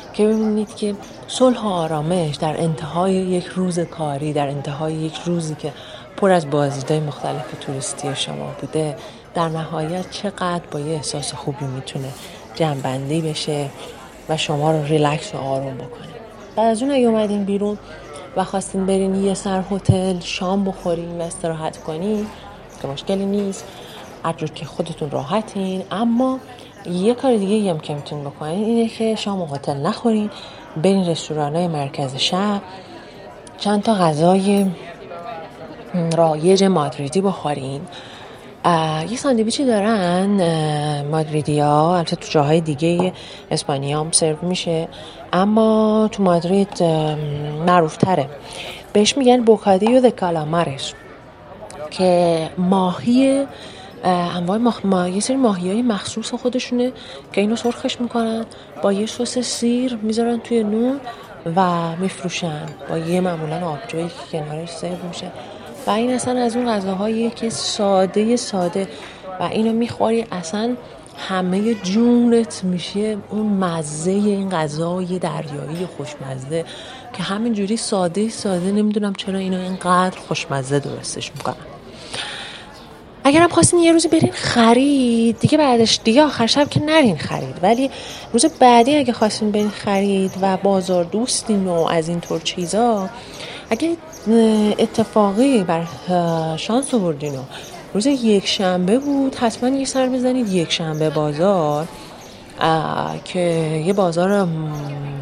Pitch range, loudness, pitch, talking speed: 160-220 Hz, -19 LUFS, 185 Hz, 130 wpm